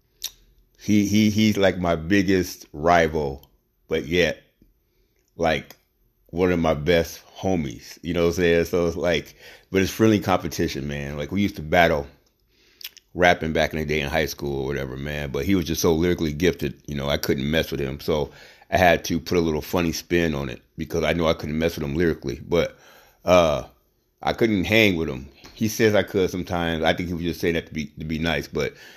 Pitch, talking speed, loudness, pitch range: 85 Hz, 215 wpm, -23 LUFS, 75-90 Hz